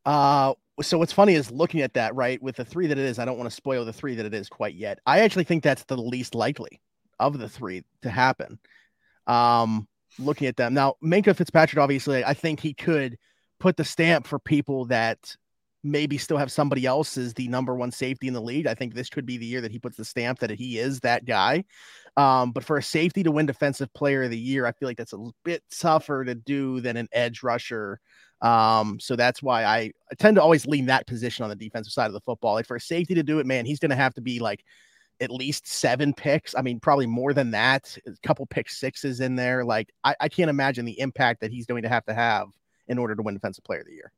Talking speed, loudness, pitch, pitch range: 250 wpm, -24 LUFS, 130 Hz, 120-145 Hz